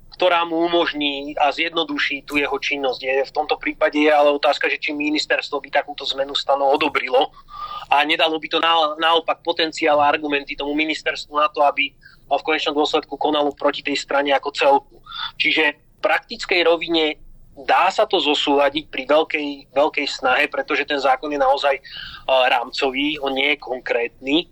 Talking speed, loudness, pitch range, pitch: 165 wpm, -19 LUFS, 140-165 Hz, 150 Hz